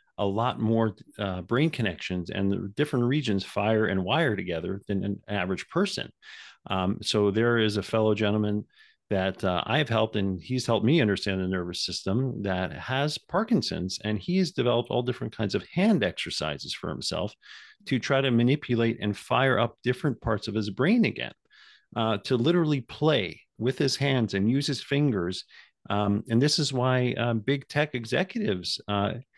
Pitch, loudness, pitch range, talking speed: 115 Hz, -27 LUFS, 100-130 Hz, 180 wpm